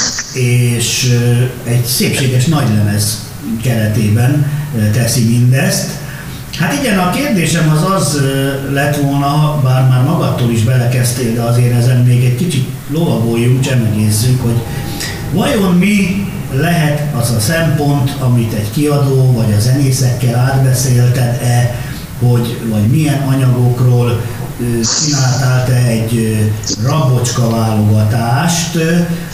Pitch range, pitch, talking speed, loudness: 120-145 Hz, 125 Hz, 105 wpm, -12 LUFS